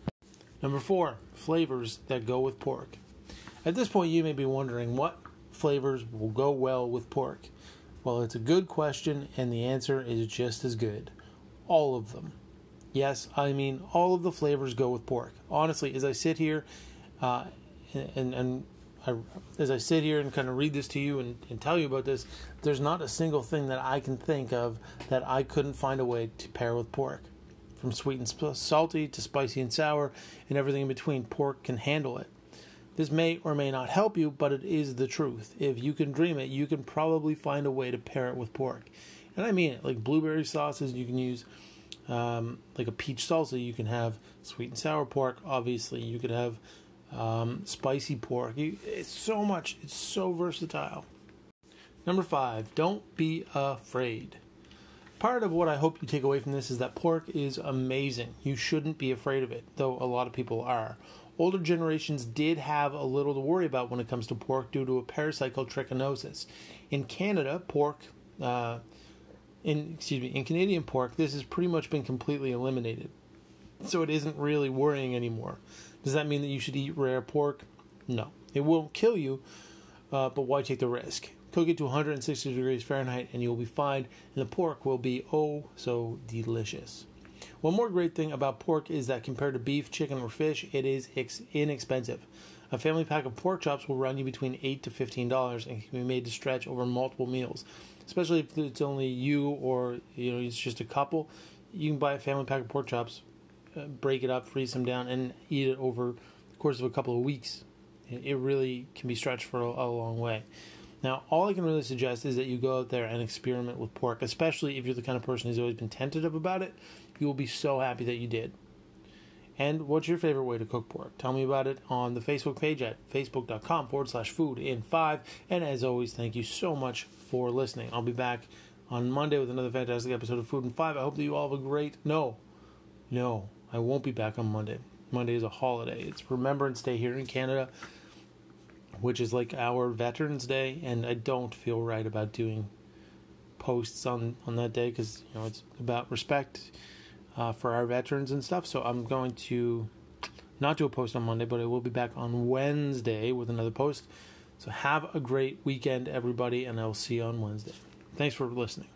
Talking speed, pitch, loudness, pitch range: 205 wpm, 130 Hz, -32 LUFS, 120-145 Hz